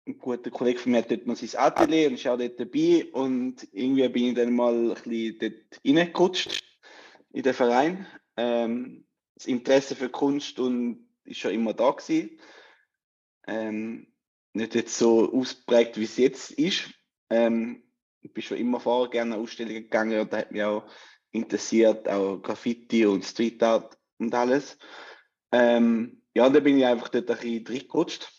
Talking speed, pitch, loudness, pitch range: 165 wpm, 120 Hz, -25 LUFS, 115-130 Hz